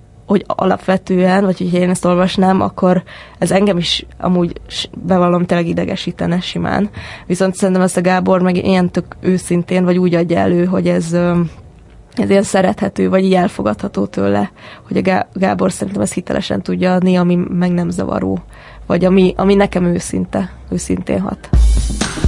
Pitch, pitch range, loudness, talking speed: 180 Hz, 175-185 Hz, -15 LUFS, 155 wpm